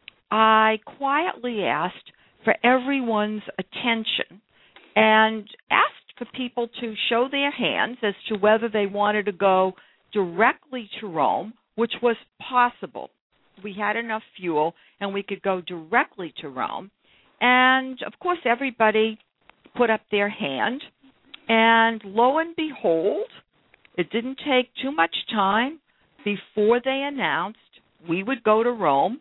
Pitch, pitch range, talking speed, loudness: 225 Hz, 205-255 Hz, 130 wpm, -23 LUFS